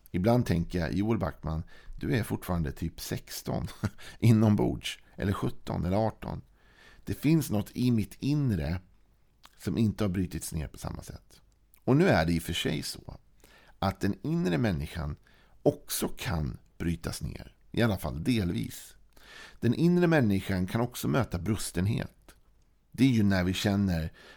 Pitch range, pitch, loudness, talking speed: 85-115 Hz, 95 Hz, -30 LUFS, 160 wpm